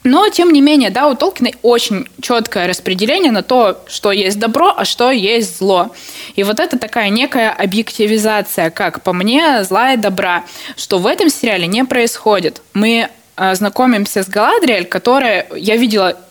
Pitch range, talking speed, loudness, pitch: 200-255 Hz, 160 wpm, -13 LUFS, 220 Hz